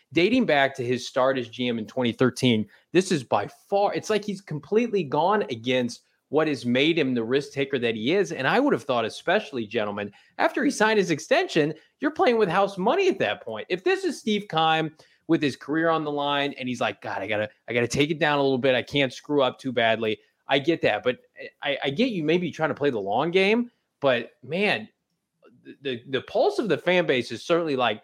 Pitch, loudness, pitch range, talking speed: 150 Hz, -24 LUFS, 125-195 Hz, 230 wpm